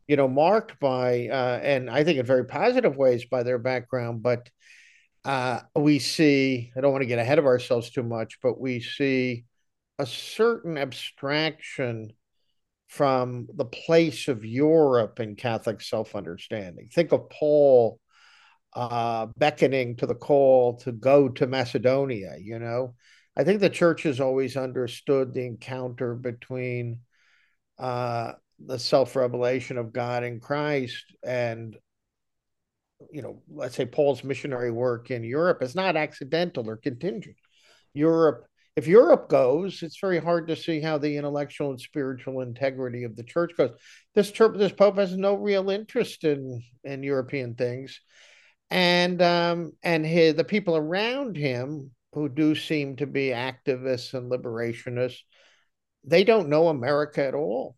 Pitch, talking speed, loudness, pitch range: 135 Hz, 145 wpm, -25 LUFS, 125-155 Hz